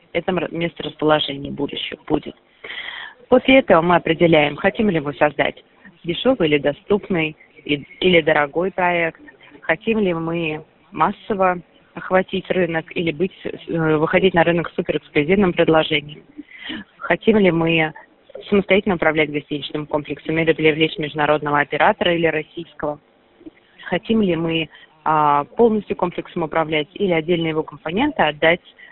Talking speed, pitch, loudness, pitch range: 120 wpm, 165 Hz, -19 LUFS, 155-190 Hz